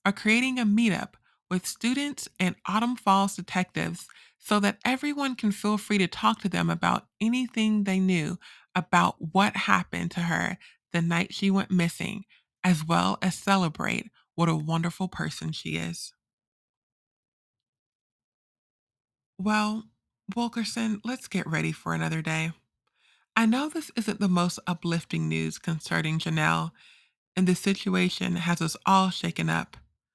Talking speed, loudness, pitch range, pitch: 140 wpm, -27 LUFS, 155-210 Hz, 180 Hz